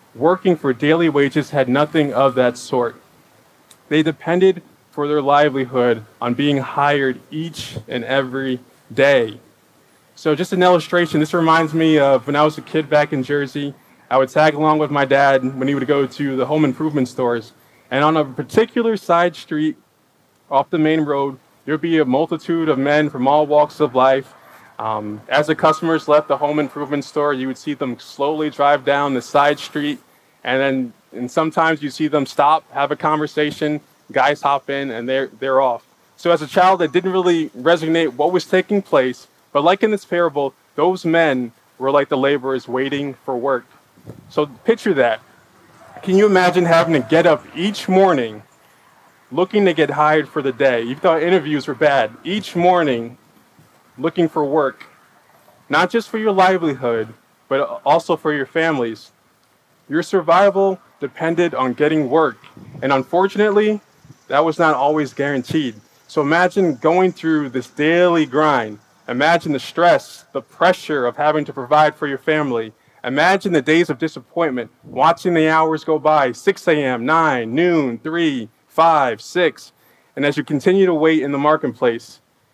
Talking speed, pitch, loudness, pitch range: 170 wpm, 150 Hz, -17 LUFS, 135-165 Hz